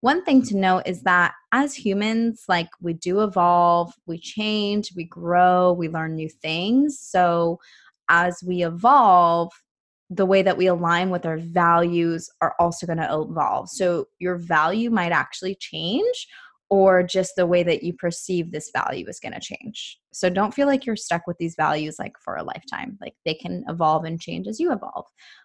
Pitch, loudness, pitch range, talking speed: 180 Hz, -22 LUFS, 170-205 Hz, 185 wpm